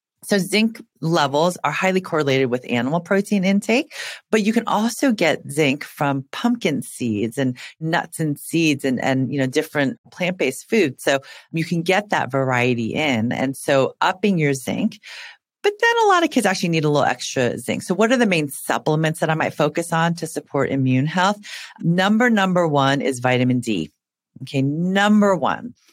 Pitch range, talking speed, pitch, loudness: 135-200 Hz, 180 wpm, 165 Hz, -20 LUFS